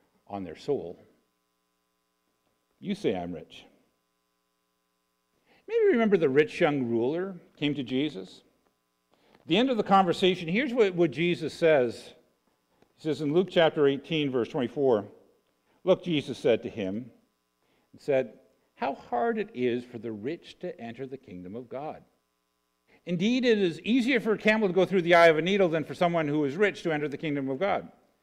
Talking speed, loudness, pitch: 175 wpm, -27 LUFS, 145 Hz